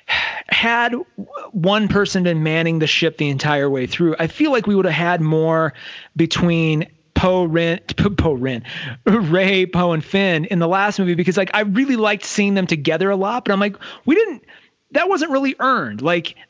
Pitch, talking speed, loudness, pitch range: 185 Hz, 180 wpm, -18 LUFS, 165-210 Hz